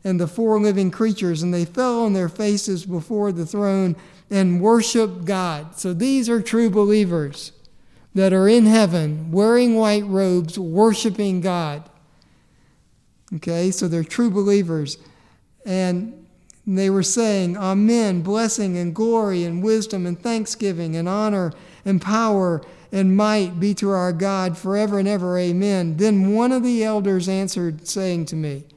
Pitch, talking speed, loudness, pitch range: 190 Hz, 150 wpm, -20 LUFS, 175-210 Hz